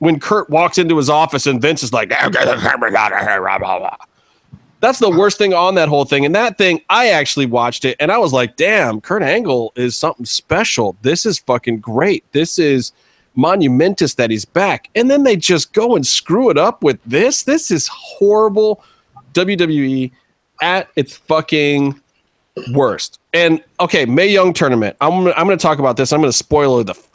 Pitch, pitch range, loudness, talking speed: 155 Hz, 135-185 Hz, -14 LUFS, 180 wpm